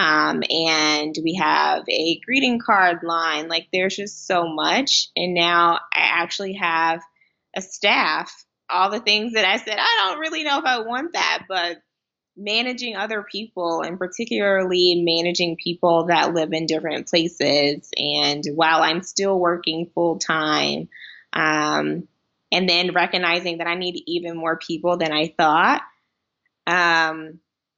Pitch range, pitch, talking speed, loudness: 160-190 Hz, 170 Hz, 145 wpm, -20 LUFS